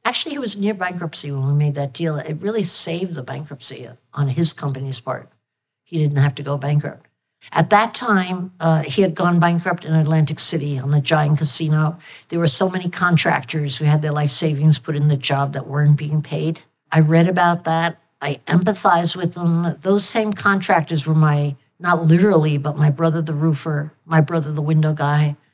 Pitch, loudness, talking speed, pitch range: 160 Hz, -19 LUFS, 195 wpm, 145-170 Hz